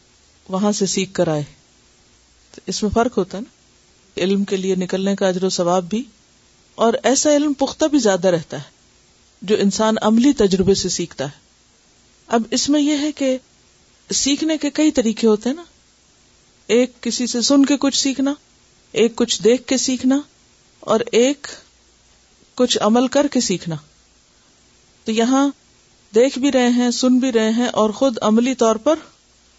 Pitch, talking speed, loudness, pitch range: 225 Hz, 165 wpm, -18 LUFS, 190-265 Hz